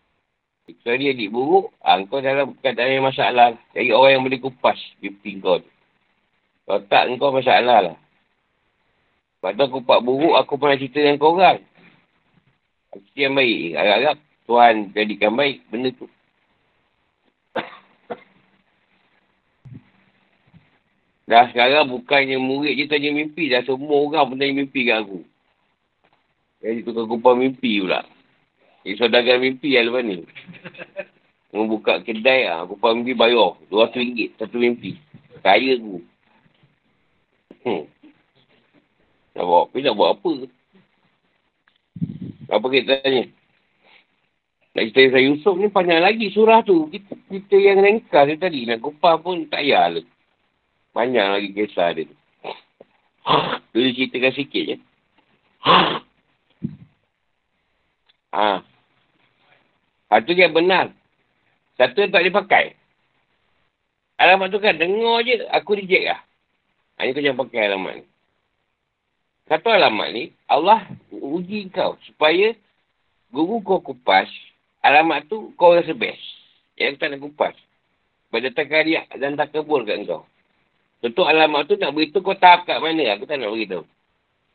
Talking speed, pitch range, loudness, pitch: 135 wpm, 120-180 Hz, -18 LUFS, 140 Hz